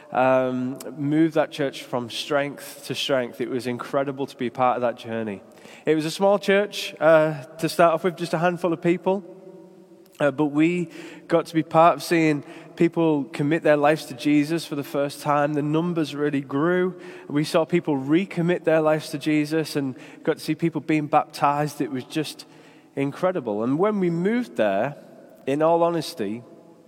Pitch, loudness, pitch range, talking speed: 155 Hz, -23 LUFS, 145-170 Hz, 185 wpm